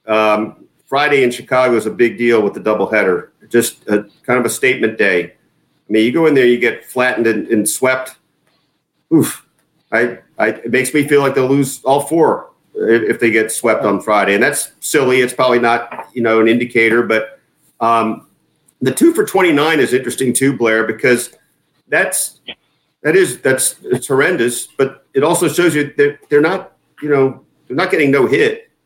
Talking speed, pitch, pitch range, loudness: 190 wpm, 125 Hz, 115-145 Hz, -14 LUFS